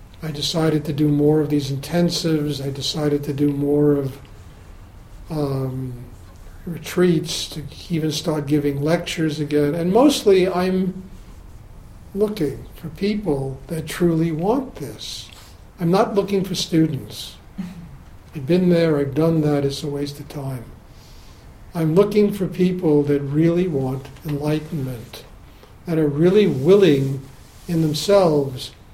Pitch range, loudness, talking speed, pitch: 135-170 Hz, -20 LUFS, 130 wpm, 150 Hz